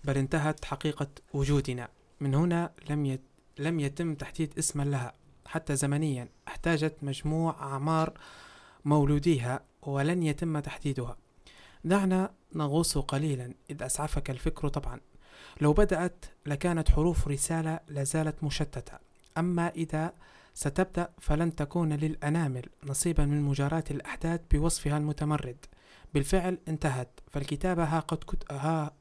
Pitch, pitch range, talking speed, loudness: 150 Hz, 140-165 Hz, 110 wpm, -31 LUFS